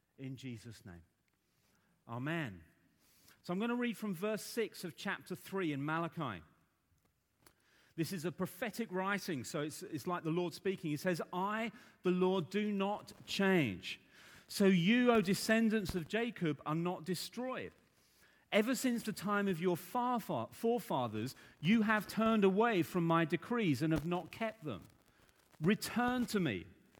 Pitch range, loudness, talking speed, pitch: 160-215 Hz, -36 LUFS, 155 wpm, 185 Hz